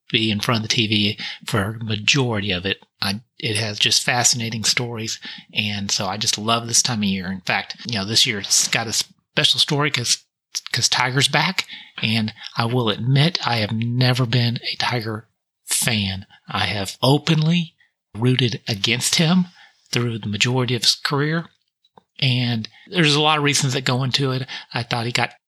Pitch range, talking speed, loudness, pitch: 110-135 Hz, 180 wpm, -19 LUFS, 120 Hz